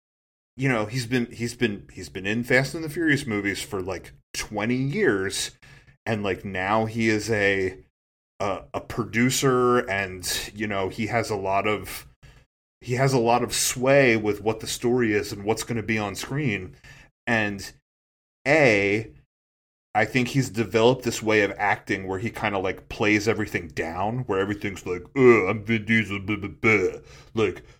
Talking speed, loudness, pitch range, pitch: 175 wpm, -24 LUFS, 100-120 Hz, 110 Hz